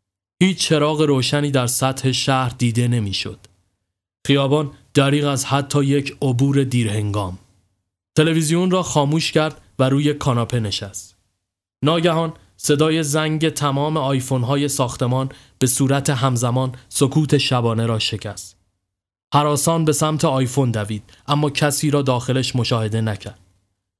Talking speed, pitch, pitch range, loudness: 120 wpm, 130 Hz, 105-145 Hz, -19 LUFS